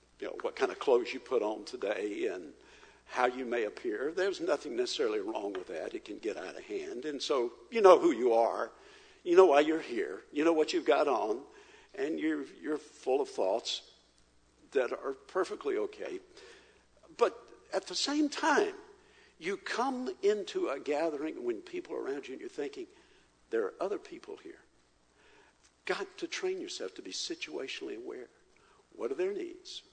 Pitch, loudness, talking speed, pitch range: 390 Hz, -33 LUFS, 180 wpm, 360-425 Hz